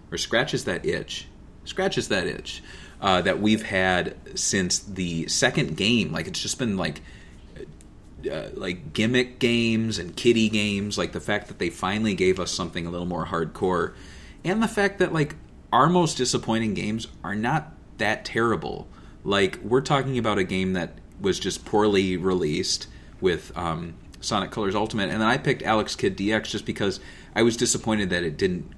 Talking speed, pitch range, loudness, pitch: 175 wpm, 95-120 Hz, -25 LUFS, 105 Hz